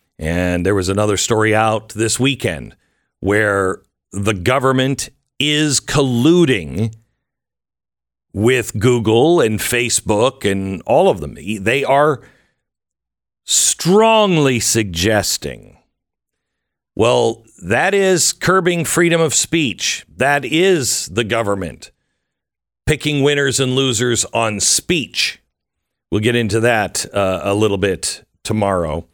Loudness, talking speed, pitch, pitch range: -16 LUFS, 105 wpm, 115 Hz, 100-140 Hz